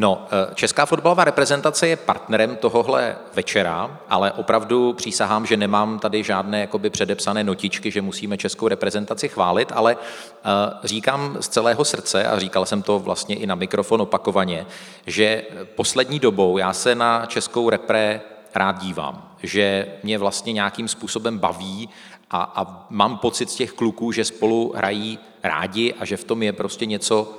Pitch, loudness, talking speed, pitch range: 110 Hz, -21 LUFS, 155 wpm, 100-115 Hz